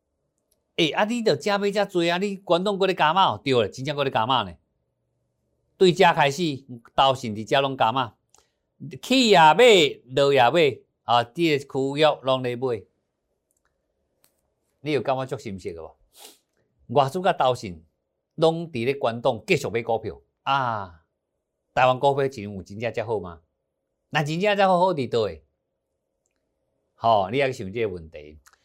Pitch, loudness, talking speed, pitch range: 130 Hz, -22 LUFS, 220 characters per minute, 100-160 Hz